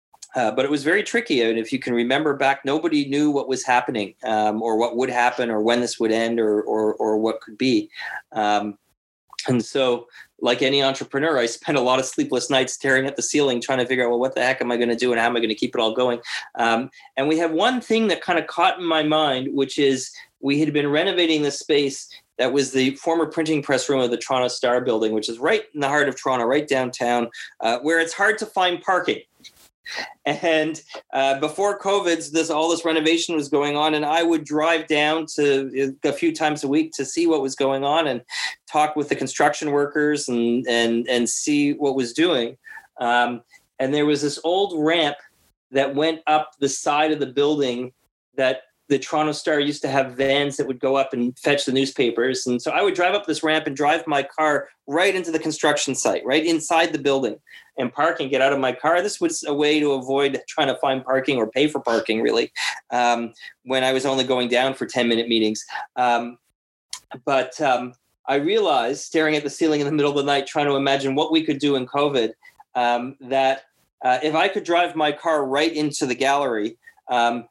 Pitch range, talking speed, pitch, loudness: 125-155 Hz, 225 wpm, 140 Hz, -21 LUFS